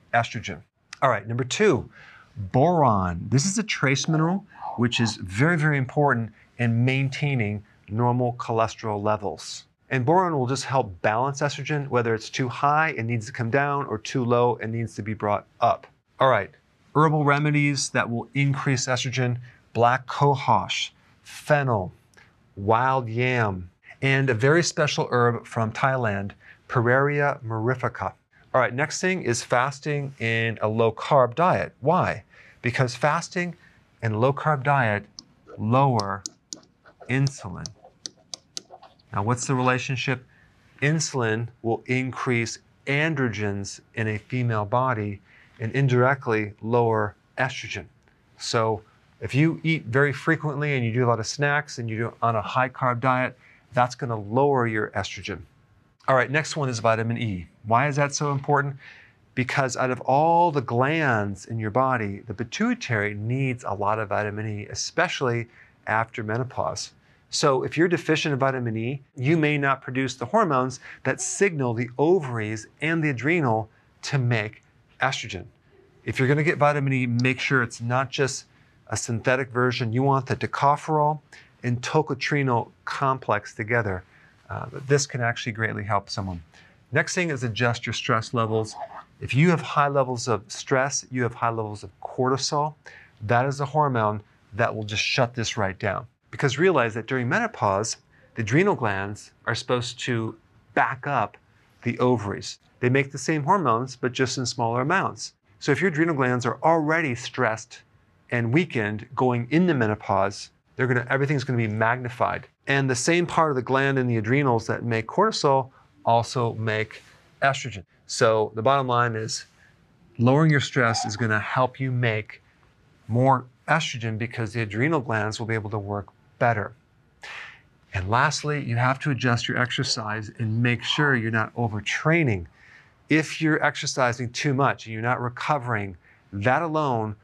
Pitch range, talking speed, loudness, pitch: 115-140 Hz, 155 wpm, -24 LUFS, 125 Hz